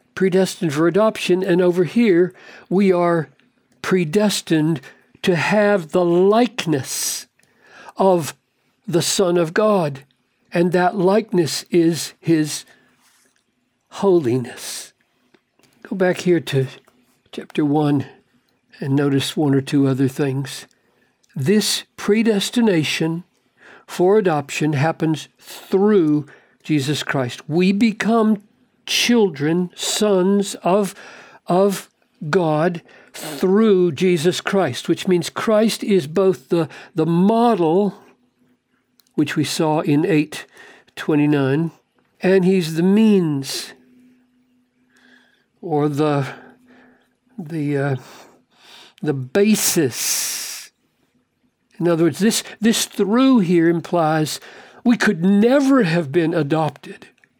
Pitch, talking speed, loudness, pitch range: 175 Hz, 100 wpm, -18 LUFS, 150-200 Hz